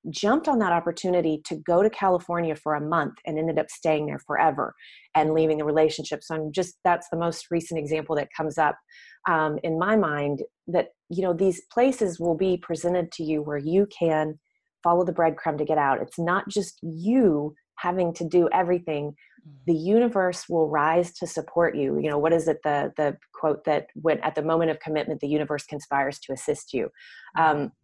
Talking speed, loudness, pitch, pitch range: 200 wpm, -25 LUFS, 165 Hz, 155-175 Hz